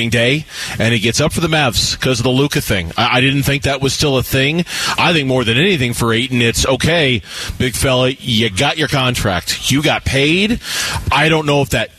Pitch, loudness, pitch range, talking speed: 130 Hz, -14 LUFS, 115-145 Hz, 225 wpm